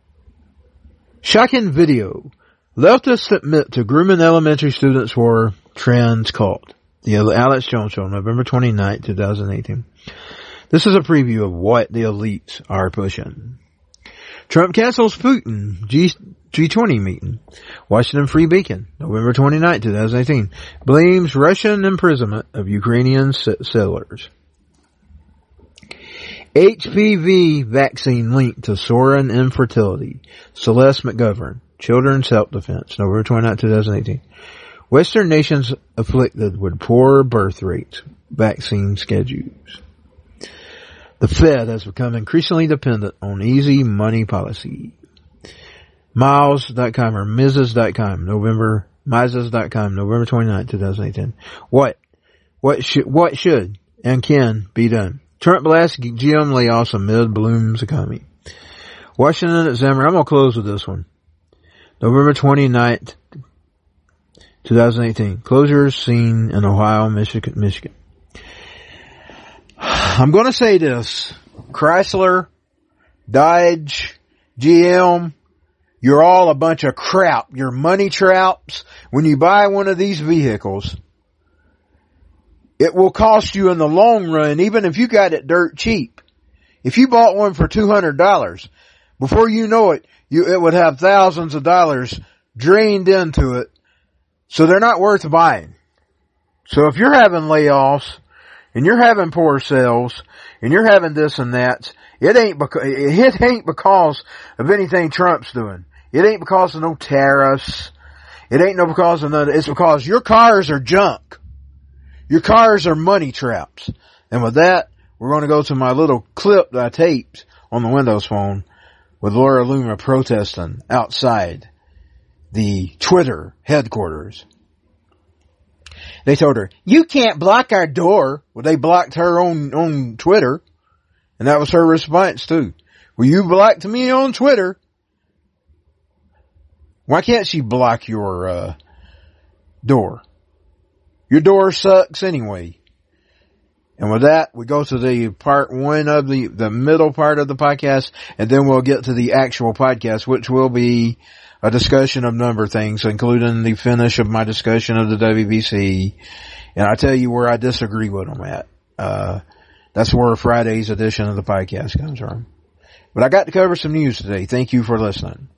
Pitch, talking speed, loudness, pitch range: 125 Hz, 140 wpm, -14 LUFS, 105-160 Hz